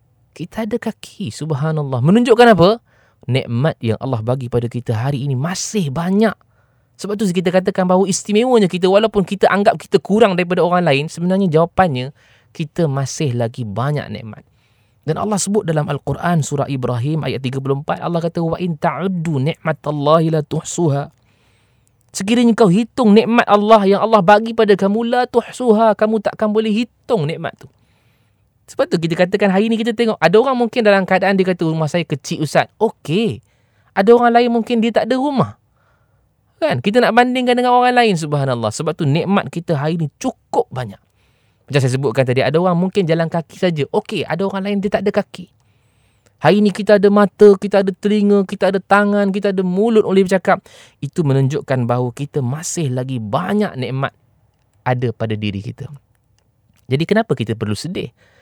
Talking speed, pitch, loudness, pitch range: 175 wpm, 165 Hz, -16 LUFS, 130-205 Hz